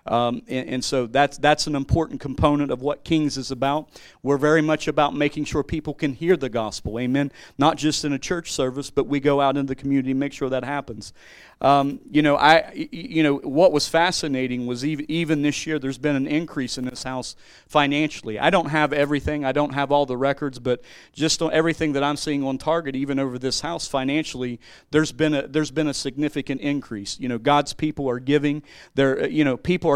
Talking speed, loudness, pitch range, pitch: 220 wpm, -22 LUFS, 135-150 Hz, 145 Hz